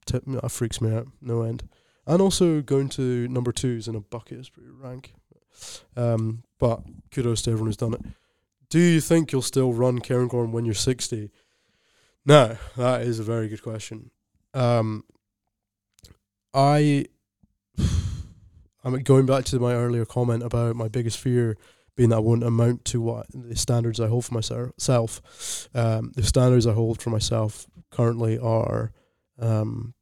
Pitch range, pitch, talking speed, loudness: 110-125 Hz, 120 Hz, 160 wpm, -24 LUFS